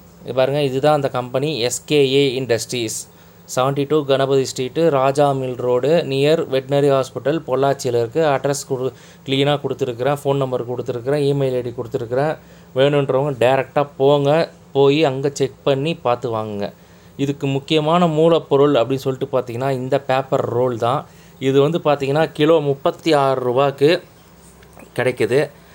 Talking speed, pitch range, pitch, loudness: 125 wpm, 130-145 Hz, 135 Hz, -18 LUFS